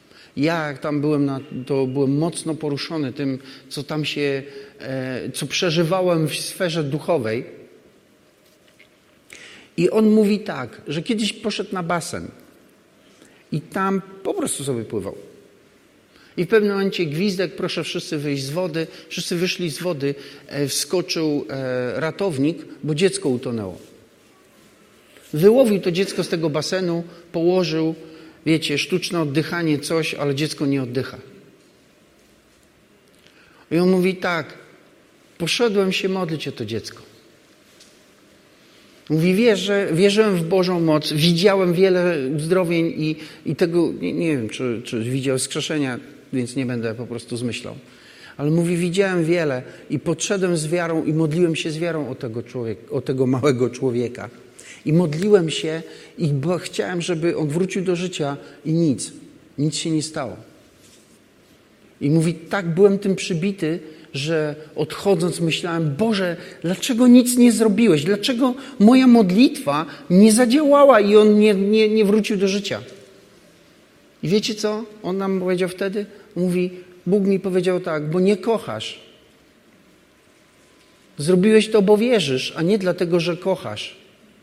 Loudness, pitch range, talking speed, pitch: -20 LUFS, 150-195 Hz, 135 wpm, 170 Hz